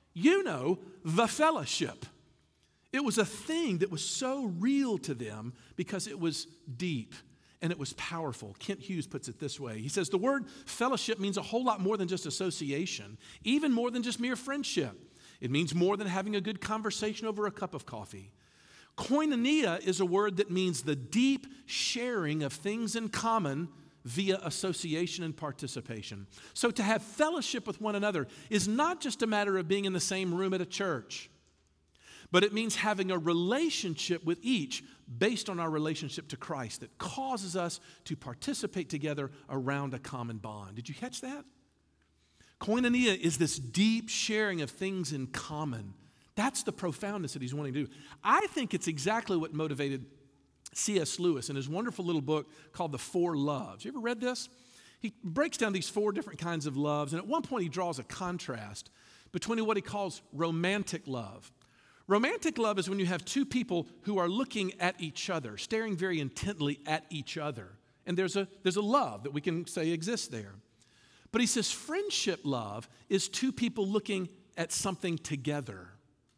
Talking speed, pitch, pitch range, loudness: 180 wpm, 180 Hz, 145-215 Hz, -33 LUFS